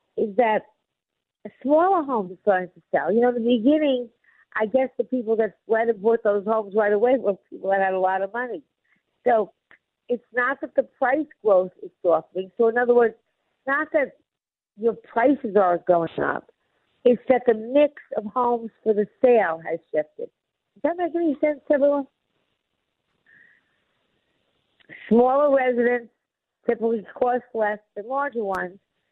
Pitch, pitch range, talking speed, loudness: 235 Hz, 210-265 Hz, 160 wpm, -23 LUFS